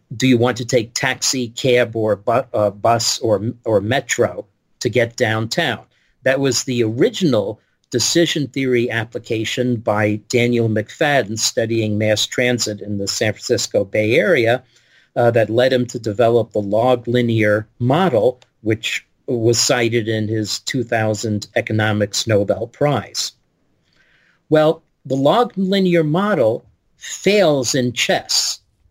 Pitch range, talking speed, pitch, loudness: 110-130 Hz, 130 wpm, 120 Hz, -18 LUFS